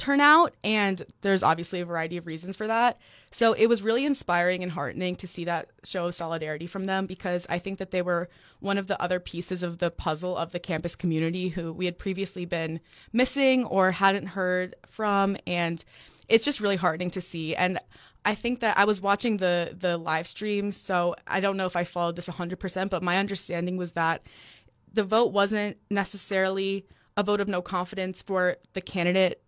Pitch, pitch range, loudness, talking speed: 185 Hz, 175-200 Hz, -27 LUFS, 195 wpm